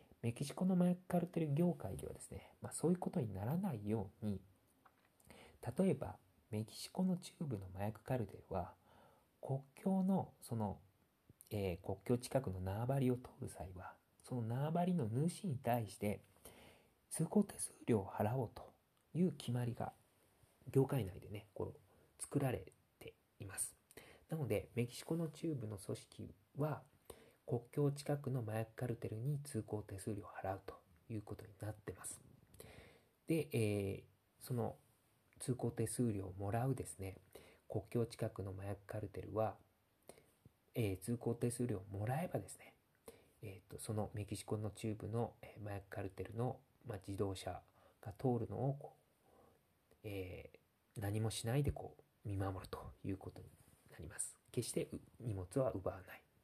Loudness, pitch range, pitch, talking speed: -43 LUFS, 100-135 Hz, 110 Hz, 275 characters per minute